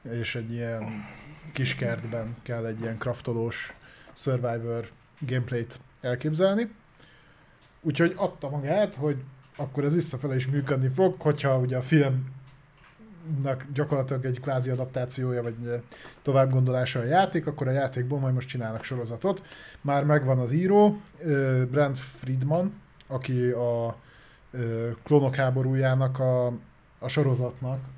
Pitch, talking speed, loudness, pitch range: 130 Hz, 120 wpm, -27 LUFS, 125-145 Hz